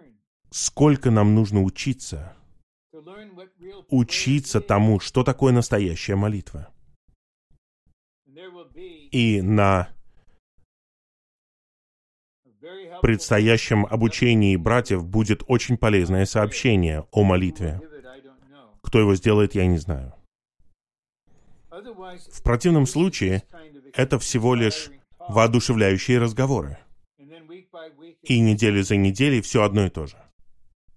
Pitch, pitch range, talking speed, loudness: 110 Hz, 95-135 Hz, 85 wpm, -21 LUFS